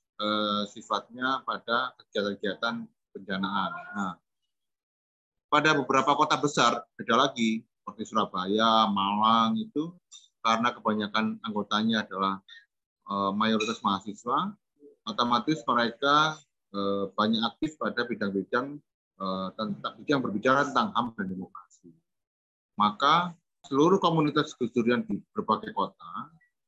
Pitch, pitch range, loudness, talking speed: 115 Hz, 105-145 Hz, -27 LUFS, 90 wpm